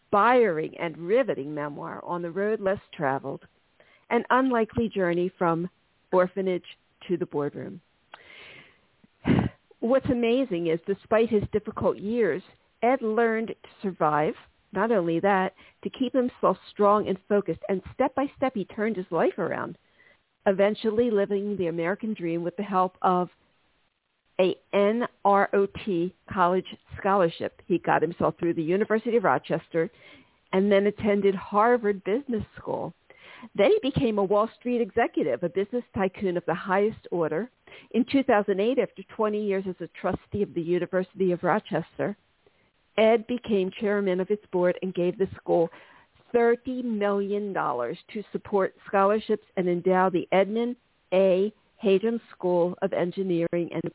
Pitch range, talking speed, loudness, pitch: 180-220 Hz, 140 wpm, -26 LUFS, 195 Hz